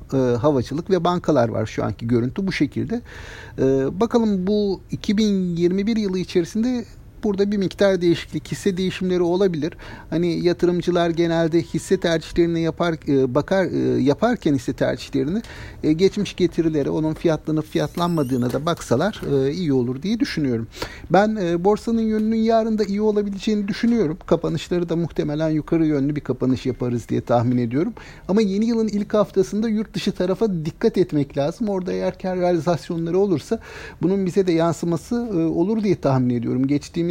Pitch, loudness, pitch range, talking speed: 170 Hz, -21 LUFS, 150-200 Hz, 140 wpm